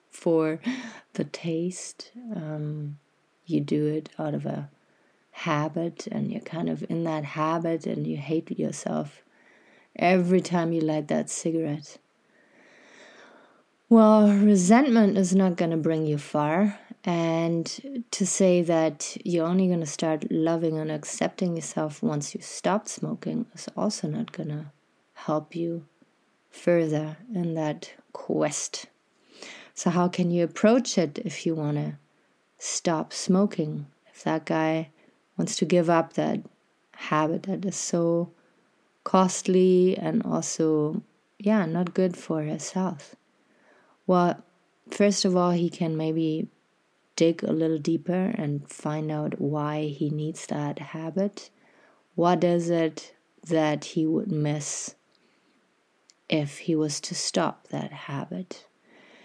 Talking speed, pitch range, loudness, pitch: 135 wpm, 155-185 Hz, -26 LUFS, 165 Hz